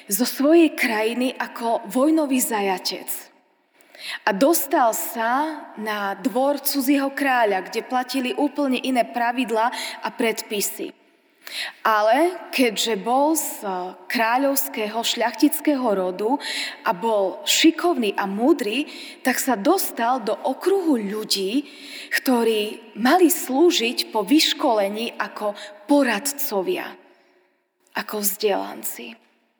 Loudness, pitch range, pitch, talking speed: -21 LUFS, 220-305 Hz, 255 Hz, 95 wpm